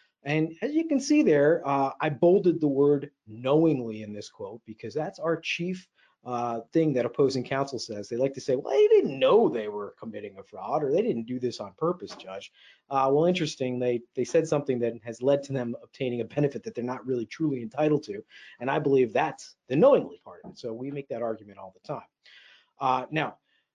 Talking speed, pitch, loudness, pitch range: 215 wpm, 135 Hz, -27 LUFS, 120-155 Hz